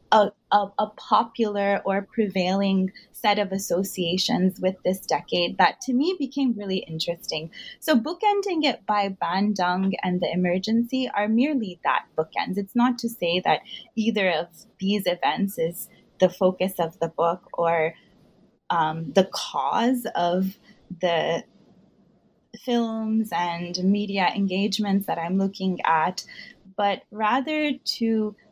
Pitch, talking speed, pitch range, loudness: 200 Hz, 130 wpm, 180-225 Hz, -24 LUFS